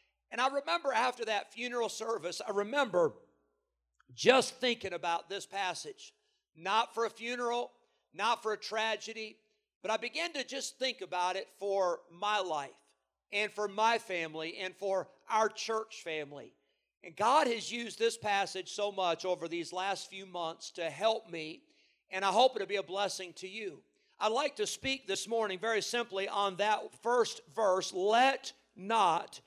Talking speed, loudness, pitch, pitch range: 165 wpm, -33 LUFS, 210 Hz, 185-235 Hz